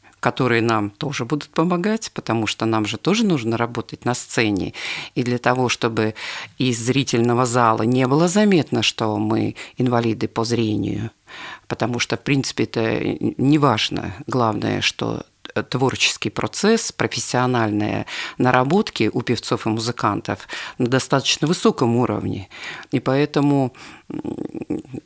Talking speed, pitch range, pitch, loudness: 125 wpm, 115-140 Hz, 120 Hz, -20 LUFS